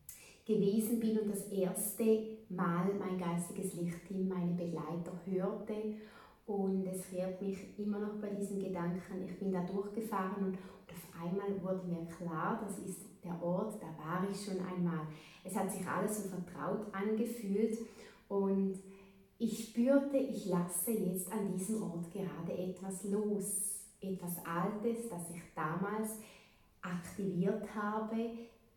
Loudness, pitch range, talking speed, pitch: -38 LUFS, 180-210 Hz, 140 wpm, 195 Hz